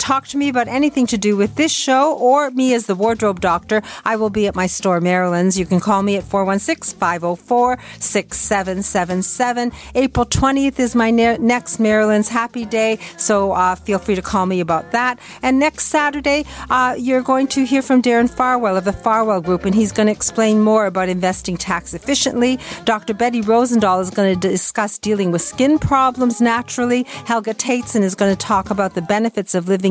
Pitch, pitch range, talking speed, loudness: 220 Hz, 195-250 Hz, 195 wpm, -16 LUFS